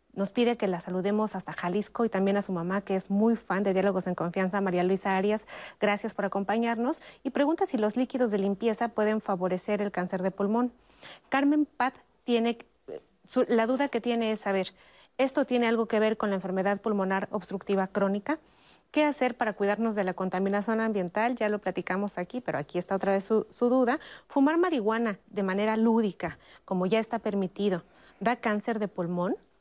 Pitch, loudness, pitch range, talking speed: 210 Hz, -28 LUFS, 195-235 Hz, 185 wpm